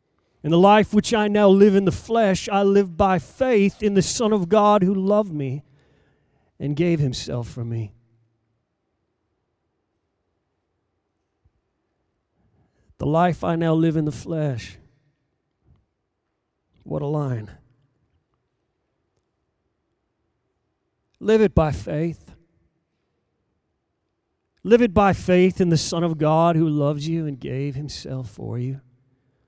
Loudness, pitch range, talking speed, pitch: -20 LUFS, 125-190 Hz, 120 wpm, 155 Hz